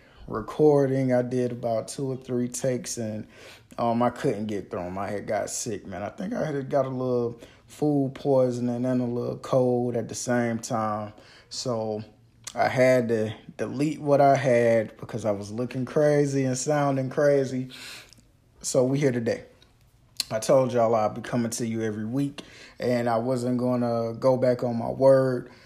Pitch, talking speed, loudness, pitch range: 125 Hz, 180 wpm, -25 LUFS, 115-130 Hz